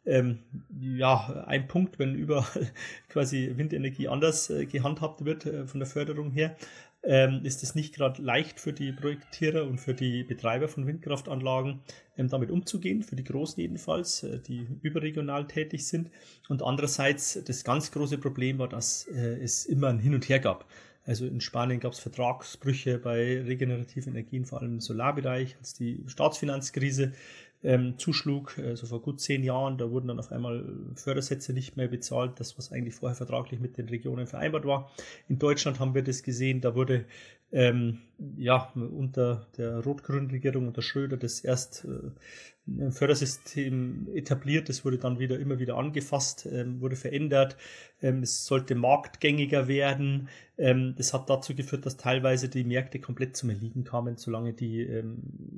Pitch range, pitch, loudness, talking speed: 125-140 Hz, 130 Hz, -30 LUFS, 160 wpm